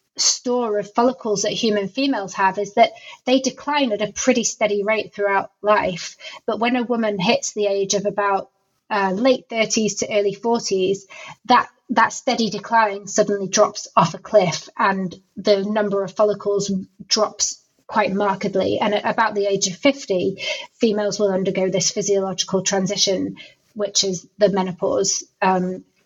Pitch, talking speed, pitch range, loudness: 205 Hz, 155 wpm, 195-225 Hz, -20 LUFS